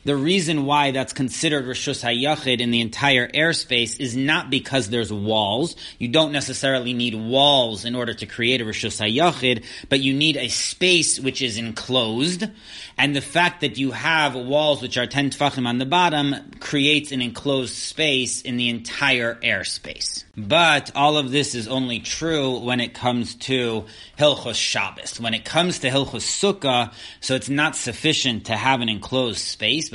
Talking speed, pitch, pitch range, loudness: 170 wpm, 130 Hz, 120-145 Hz, -21 LUFS